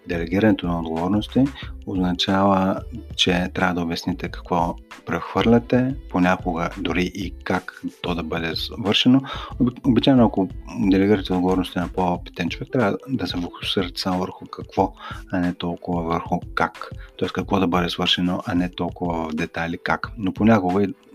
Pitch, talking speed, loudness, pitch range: 90 Hz, 145 wpm, -22 LUFS, 90-105 Hz